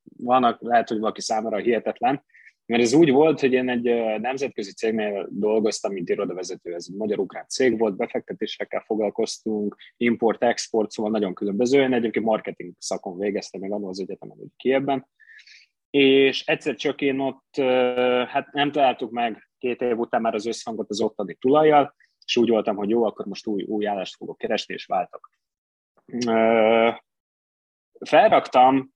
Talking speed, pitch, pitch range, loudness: 150 wpm, 115 Hz, 105-130 Hz, -23 LUFS